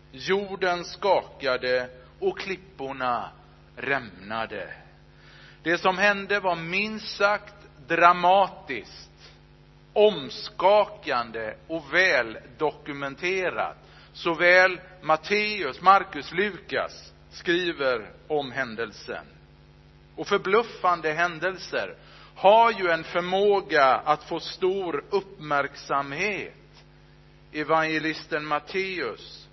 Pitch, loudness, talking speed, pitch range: 175 Hz, -25 LUFS, 70 wpm, 140-195 Hz